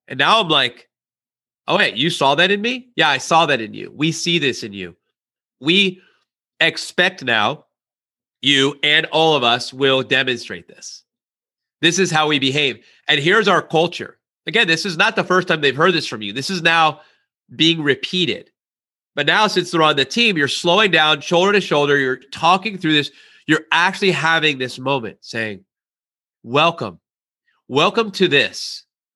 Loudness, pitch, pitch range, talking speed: -16 LUFS, 155 Hz, 135-180 Hz, 175 wpm